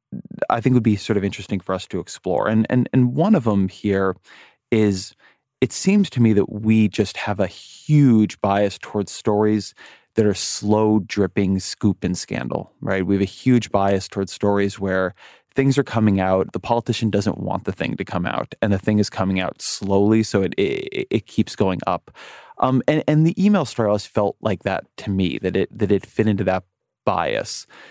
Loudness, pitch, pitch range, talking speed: -20 LUFS, 105 Hz, 95-115 Hz, 205 wpm